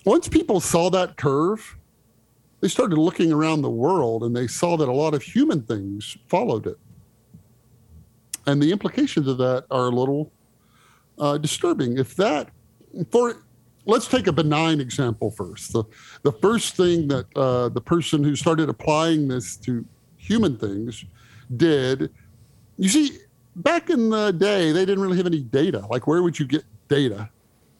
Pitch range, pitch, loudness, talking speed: 120-170 Hz, 145 Hz, -22 LUFS, 160 wpm